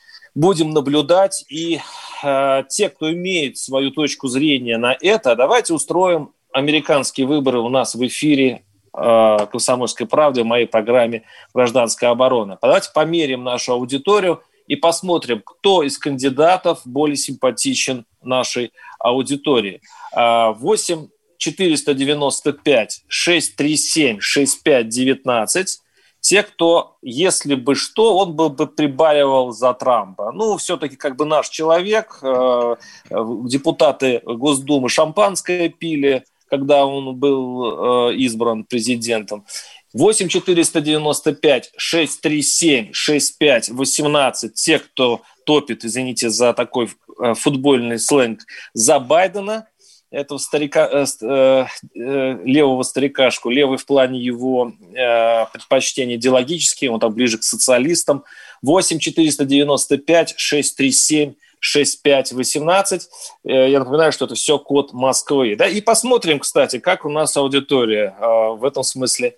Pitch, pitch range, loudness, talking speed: 140 Hz, 125-160 Hz, -17 LUFS, 125 wpm